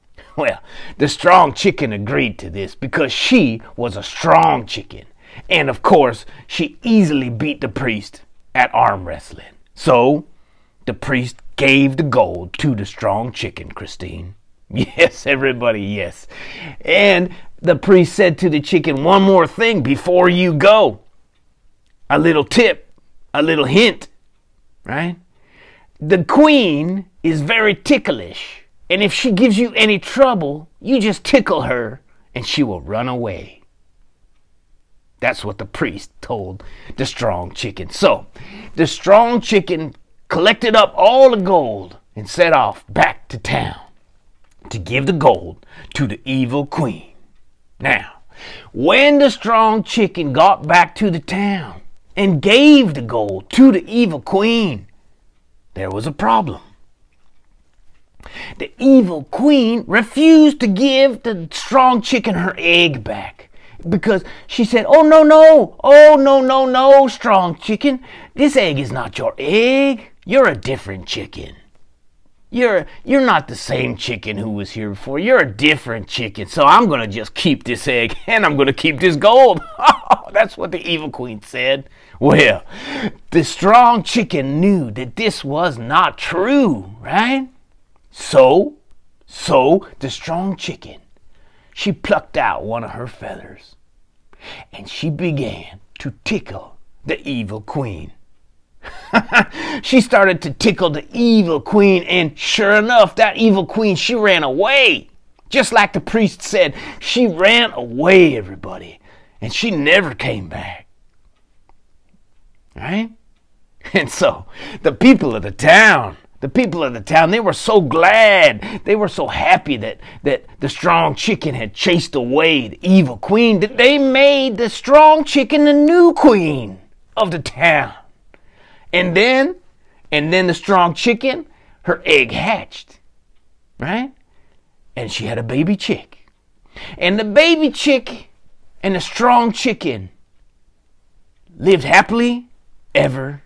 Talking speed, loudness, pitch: 140 wpm, -14 LUFS, 180 Hz